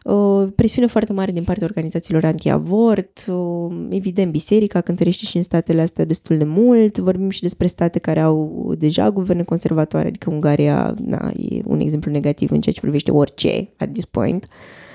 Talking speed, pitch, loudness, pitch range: 175 wpm, 175 Hz, -18 LUFS, 160-200 Hz